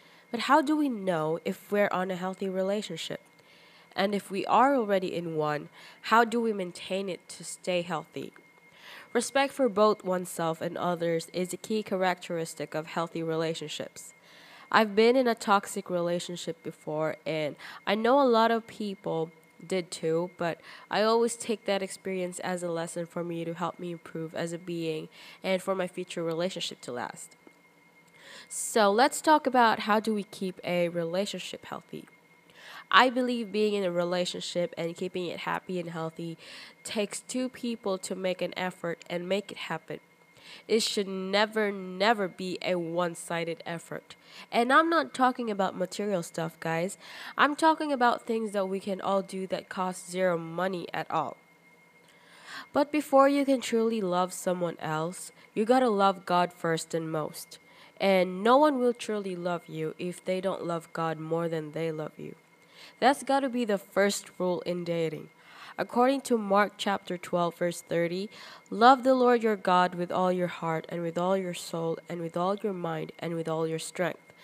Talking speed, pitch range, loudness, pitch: 175 wpm, 170-210 Hz, -29 LUFS, 185 Hz